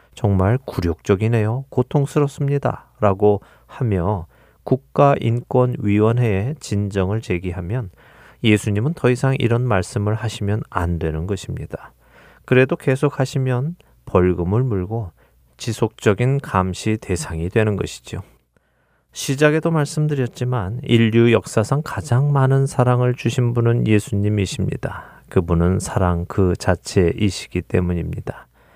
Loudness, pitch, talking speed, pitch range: -19 LUFS, 110 Hz, 275 characters per minute, 95-130 Hz